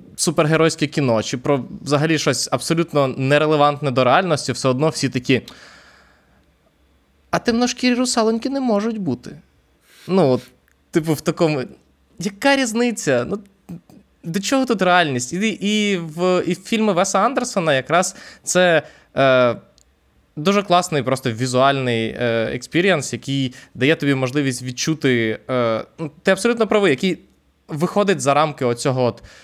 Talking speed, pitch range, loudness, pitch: 135 wpm, 130-190 Hz, -19 LUFS, 155 Hz